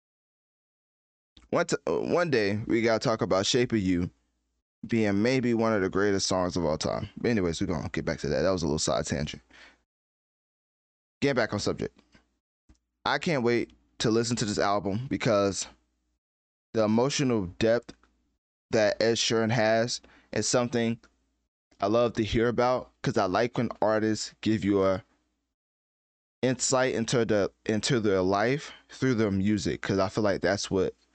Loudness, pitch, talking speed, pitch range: -27 LUFS, 105 Hz, 170 wpm, 90-115 Hz